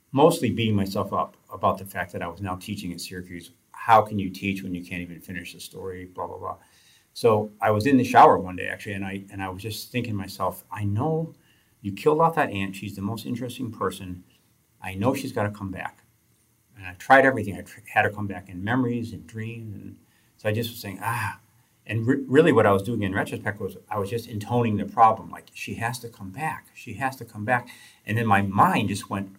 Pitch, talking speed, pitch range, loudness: 105 Hz, 240 wpm, 95-115 Hz, -24 LUFS